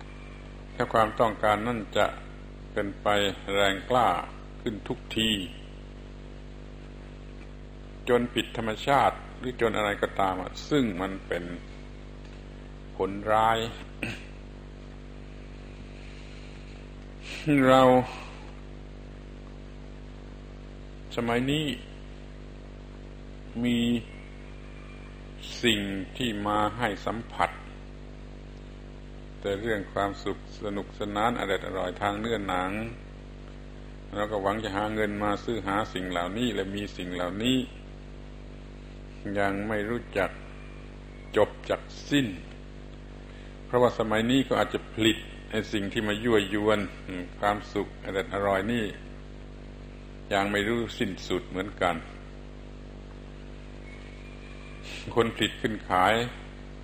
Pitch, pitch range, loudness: 105 Hz, 100-120 Hz, -28 LUFS